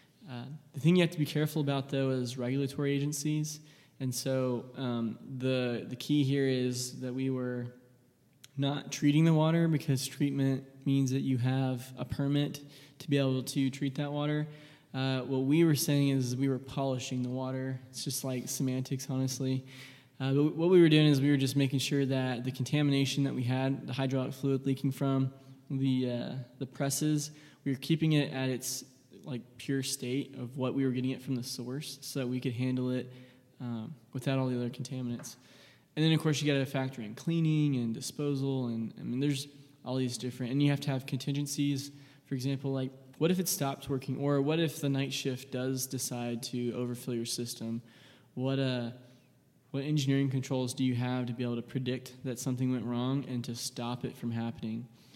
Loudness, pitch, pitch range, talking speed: -32 LUFS, 135 Hz, 125-140 Hz, 200 wpm